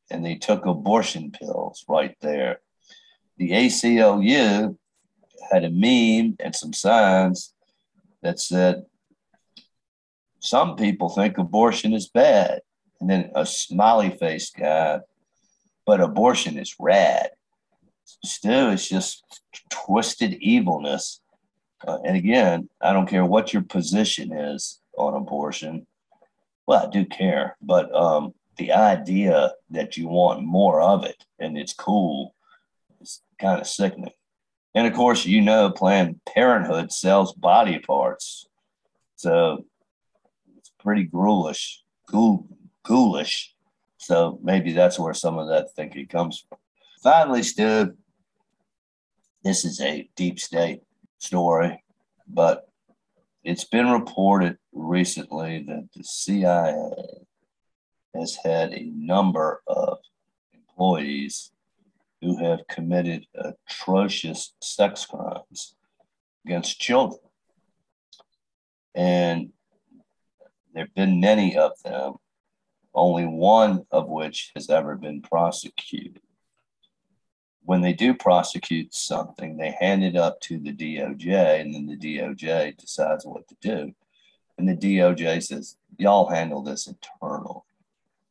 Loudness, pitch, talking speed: -22 LUFS, 95 Hz, 115 wpm